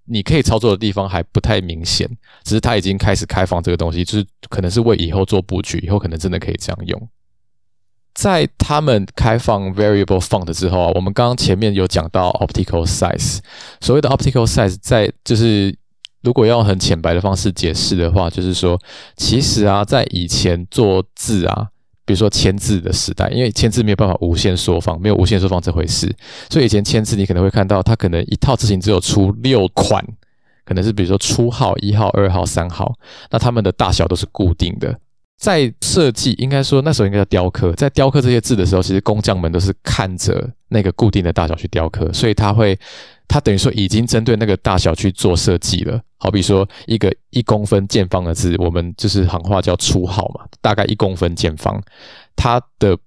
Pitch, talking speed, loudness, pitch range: 100 Hz, 340 characters per minute, -16 LUFS, 90-115 Hz